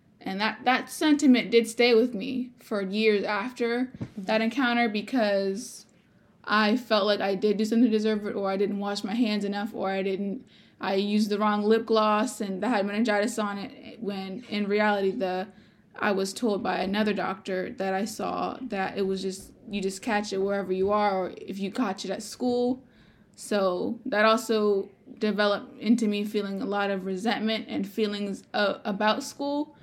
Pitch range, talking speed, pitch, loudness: 200-230 Hz, 185 wpm, 210 Hz, -27 LUFS